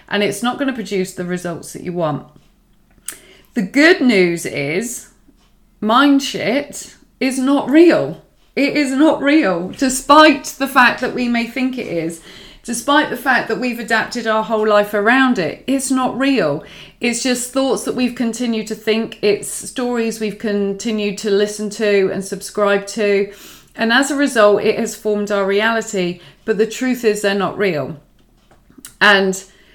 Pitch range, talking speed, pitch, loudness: 200-255 Hz, 165 wpm, 220 Hz, -16 LUFS